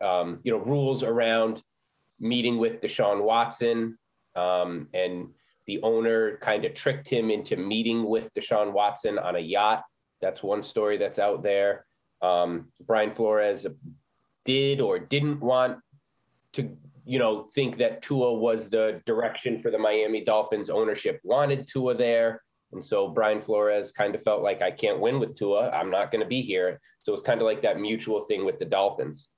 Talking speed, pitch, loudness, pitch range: 175 wpm, 115 Hz, -26 LUFS, 105-135 Hz